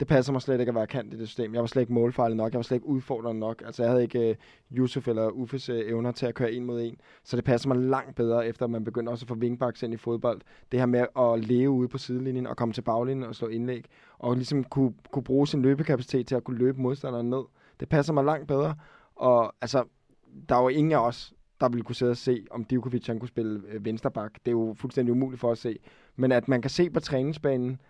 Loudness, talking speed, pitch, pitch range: -28 LUFS, 265 wpm, 125 Hz, 115-130 Hz